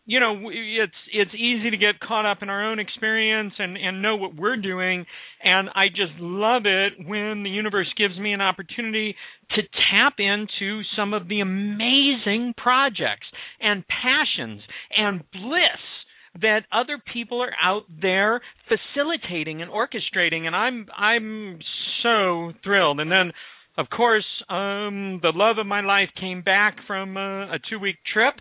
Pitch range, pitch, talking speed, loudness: 190-220 Hz, 205 Hz, 155 wpm, -22 LUFS